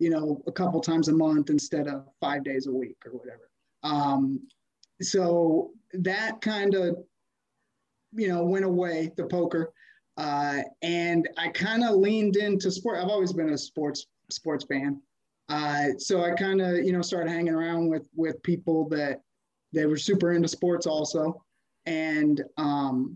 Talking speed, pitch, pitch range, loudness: 165 wpm, 165 Hz, 150-180 Hz, -27 LUFS